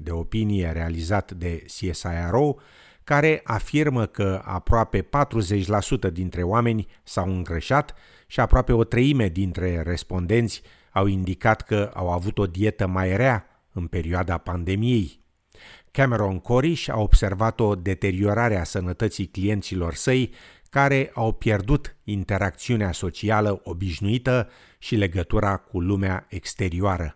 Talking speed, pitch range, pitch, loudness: 115 wpm, 90-115 Hz, 100 Hz, -24 LUFS